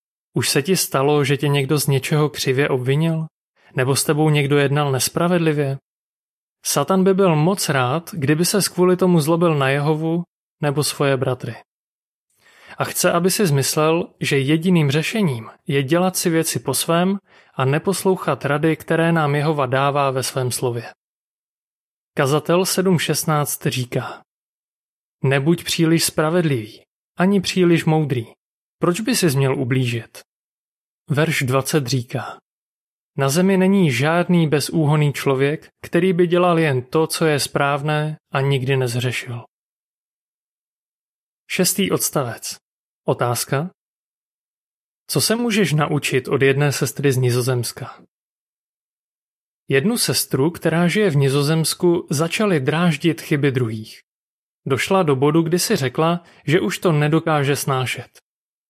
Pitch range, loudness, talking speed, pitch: 135-170 Hz, -19 LUFS, 125 wpm, 150 Hz